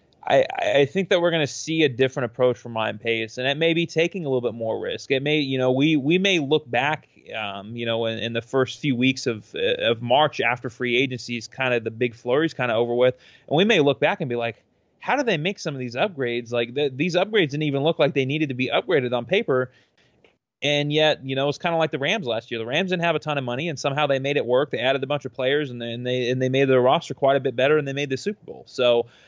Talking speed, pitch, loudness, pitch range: 285 wpm, 135 Hz, -23 LUFS, 120-150 Hz